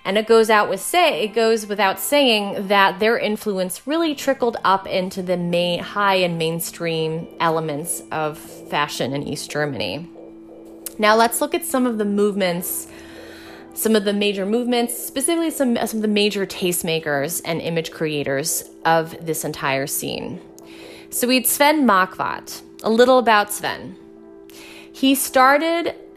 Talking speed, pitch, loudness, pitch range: 150 wpm, 190 Hz, -19 LUFS, 160-230 Hz